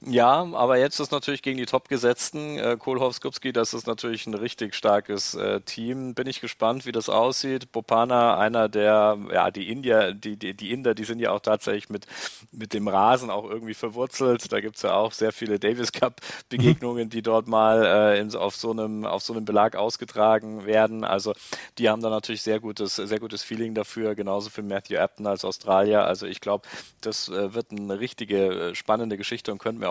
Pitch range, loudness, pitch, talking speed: 105-120 Hz, -25 LUFS, 110 Hz, 195 wpm